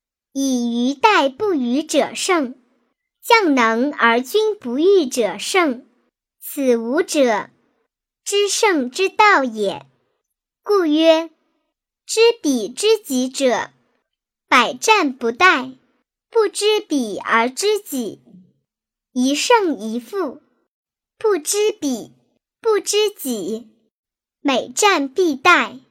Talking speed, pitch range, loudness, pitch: 125 characters per minute, 250-405 Hz, -17 LUFS, 300 Hz